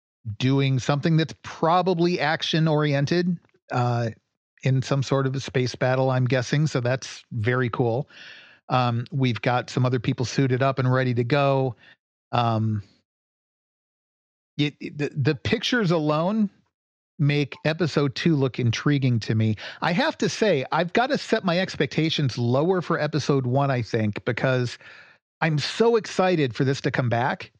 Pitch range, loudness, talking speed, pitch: 125-160 Hz, -24 LUFS, 155 wpm, 135 Hz